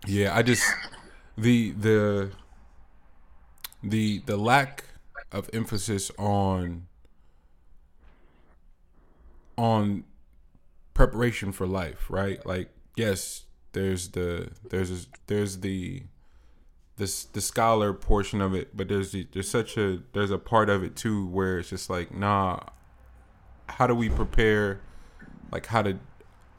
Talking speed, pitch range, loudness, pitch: 120 wpm, 80-105 Hz, -27 LUFS, 95 Hz